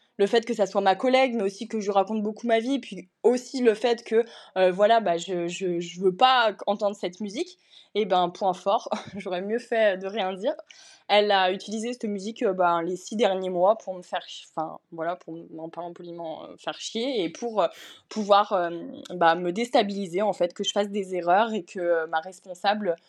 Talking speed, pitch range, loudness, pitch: 220 wpm, 180-225 Hz, -25 LUFS, 200 Hz